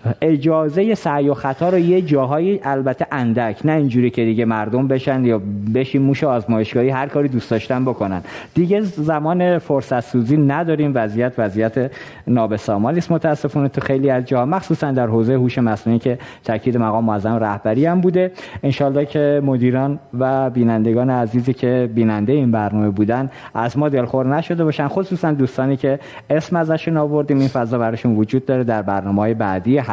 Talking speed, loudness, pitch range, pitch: 160 wpm, -18 LUFS, 115-150 Hz, 130 Hz